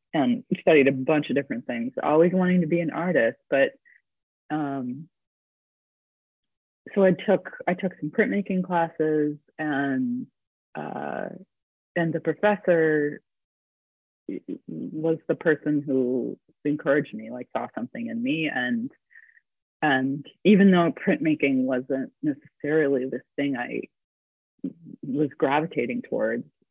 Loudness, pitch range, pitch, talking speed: -25 LUFS, 145-195 Hz, 160 Hz, 115 wpm